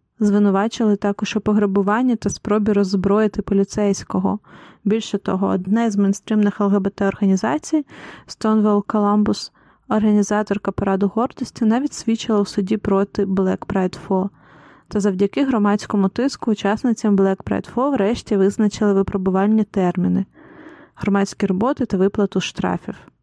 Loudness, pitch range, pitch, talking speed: -19 LUFS, 195-220 Hz, 205 Hz, 115 wpm